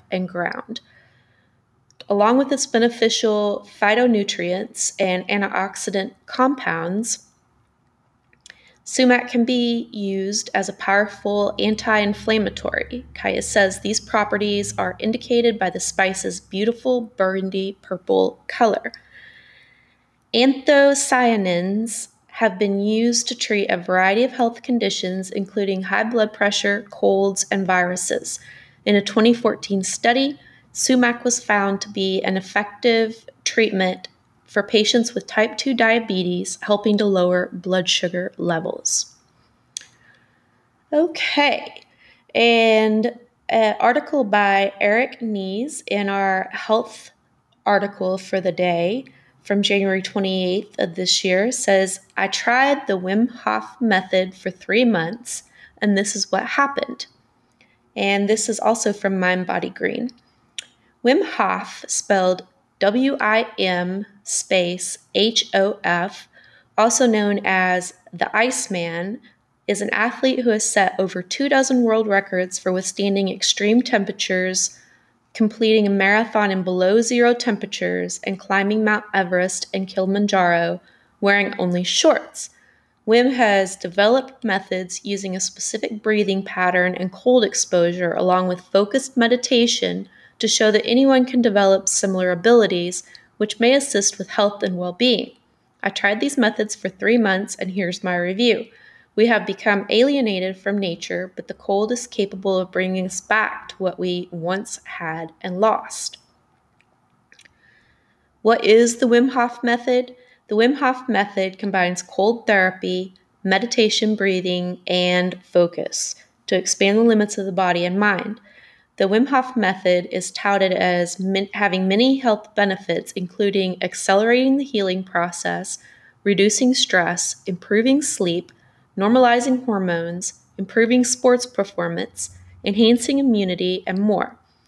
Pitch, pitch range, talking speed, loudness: 205 Hz, 185-230 Hz, 125 wpm, -19 LUFS